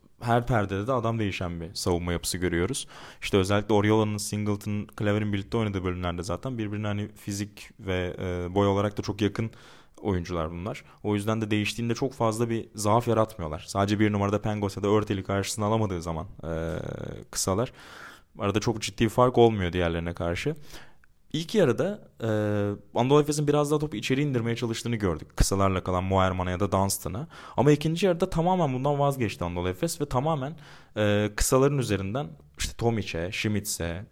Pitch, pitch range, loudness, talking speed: 105 Hz, 95-120 Hz, -27 LUFS, 160 wpm